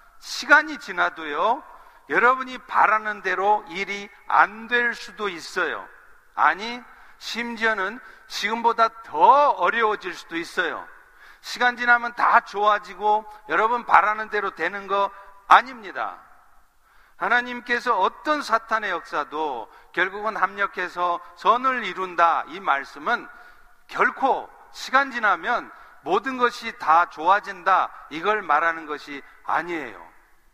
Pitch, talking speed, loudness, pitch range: 215 Hz, 250 characters per minute, -22 LUFS, 185-240 Hz